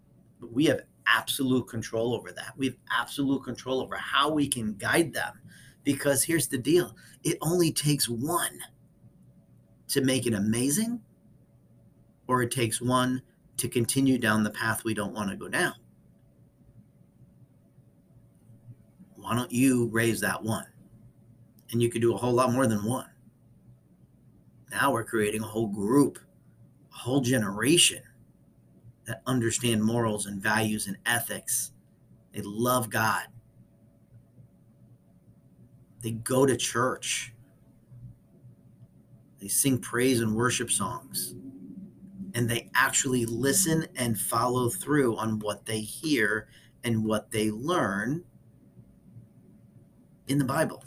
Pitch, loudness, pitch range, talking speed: 120 Hz, -27 LUFS, 110-130 Hz, 125 wpm